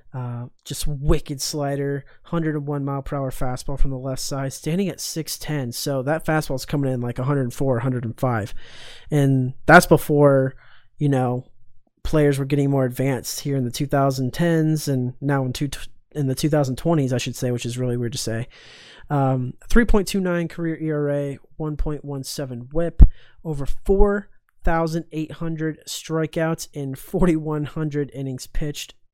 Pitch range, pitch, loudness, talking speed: 130-155 Hz, 140 Hz, -23 LUFS, 140 wpm